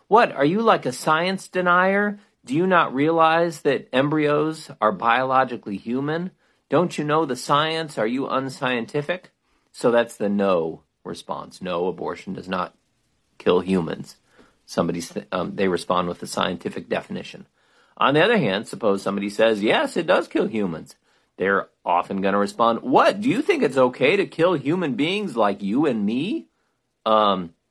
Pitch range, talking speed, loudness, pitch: 110-170 Hz, 160 wpm, -22 LUFS, 135 Hz